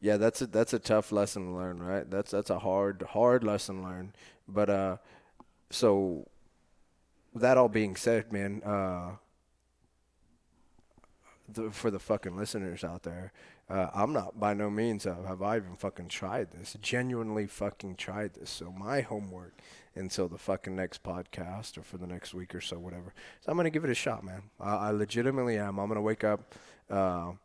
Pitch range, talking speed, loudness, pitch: 90-110 Hz, 190 wpm, -32 LUFS, 100 Hz